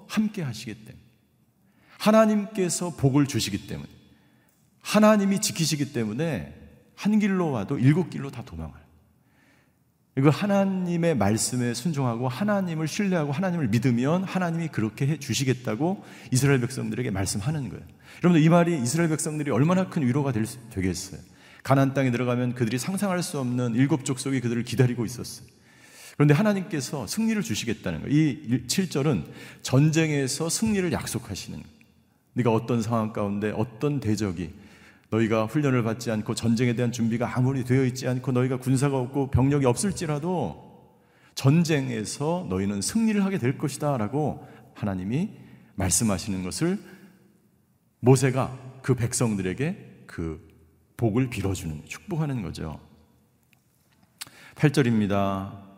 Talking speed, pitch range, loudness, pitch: 335 characters per minute, 110-160 Hz, -25 LUFS, 130 Hz